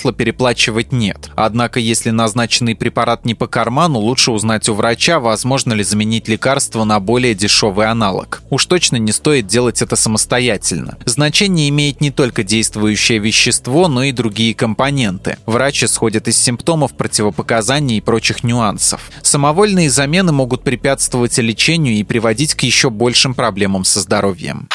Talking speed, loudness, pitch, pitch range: 145 wpm, -13 LUFS, 120 Hz, 110-135 Hz